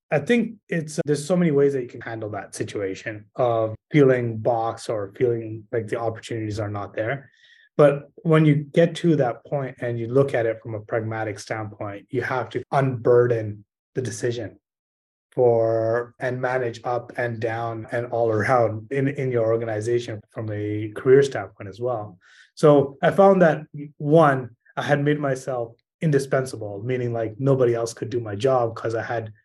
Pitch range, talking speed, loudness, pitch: 110-140 Hz, 175 wpm, -23 LUFS, 120 Hz